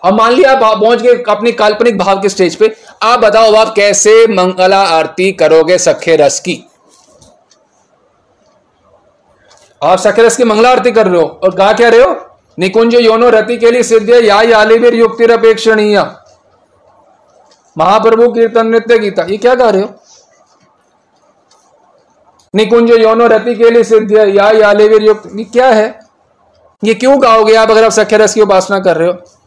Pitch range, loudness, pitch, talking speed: 205-230 Hz, -8 LUFS, 220 Hz, 145 wpm